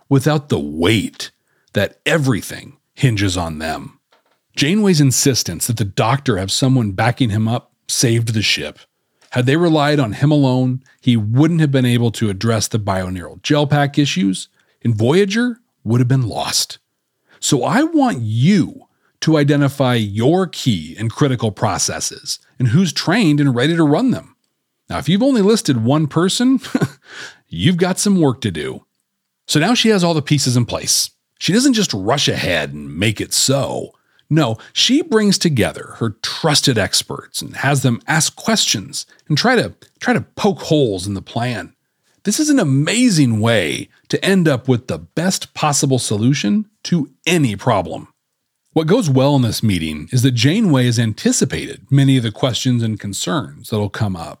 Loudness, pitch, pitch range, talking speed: -16 LUFS, 135 Hz, 115-160 Hz, 170 wpm